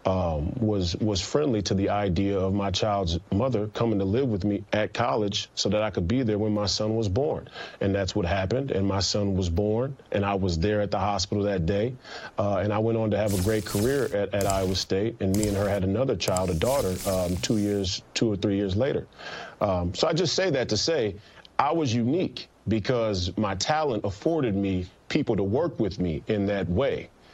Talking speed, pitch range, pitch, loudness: 225 wpm, 95-110 Hz, 100 Hz, -26 LUFS